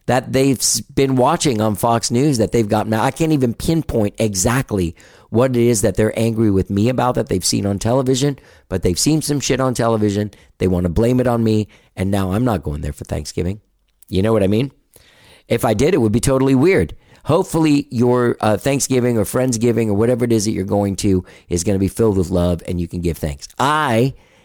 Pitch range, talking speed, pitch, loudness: 100-125 Hz, 225 wpm, 110 Hz, -17 LUFS